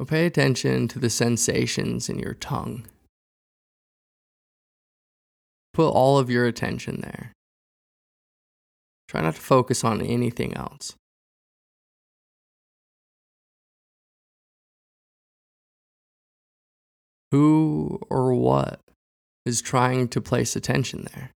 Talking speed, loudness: 85 wpm, -23 LUFS